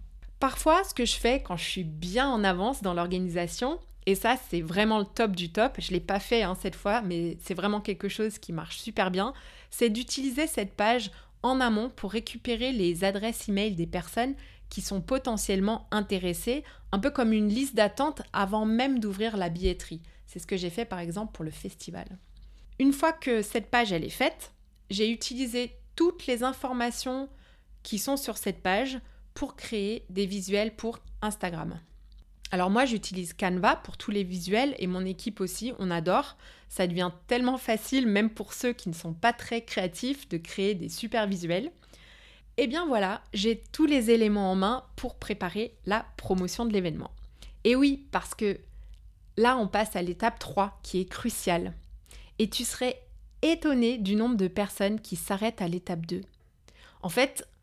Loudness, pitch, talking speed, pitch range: -29 LUFS, 210 Hz, 180 wpm, 185-245 Hz